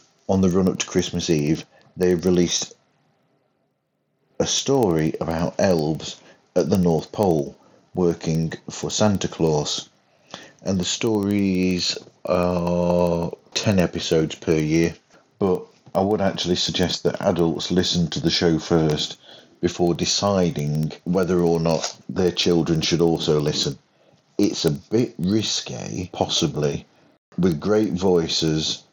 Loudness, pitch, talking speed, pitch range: -22 LUFS, 85 Hz, 120 wpm, 80-90 Hz